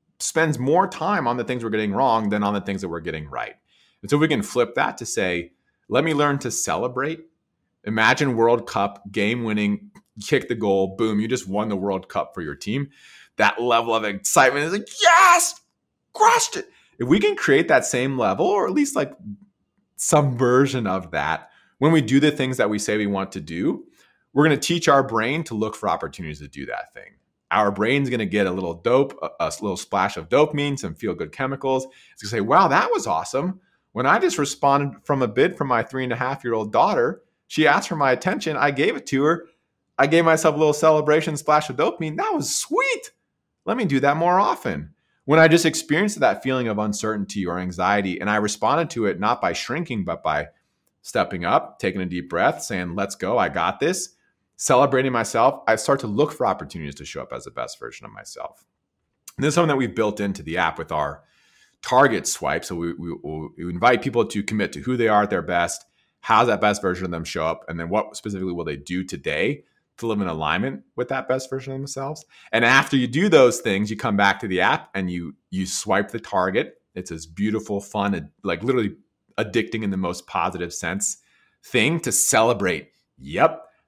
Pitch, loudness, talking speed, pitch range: 125 Hz, -21 LUFS, 215 wpm, 100-150 Hz